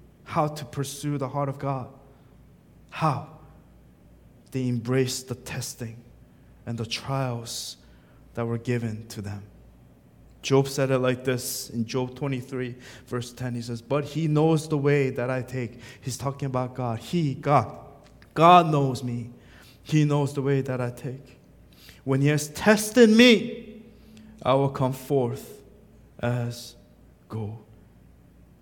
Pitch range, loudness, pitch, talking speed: 120-140 Hz, -25 LUFS, 130 Hz, 140 wpm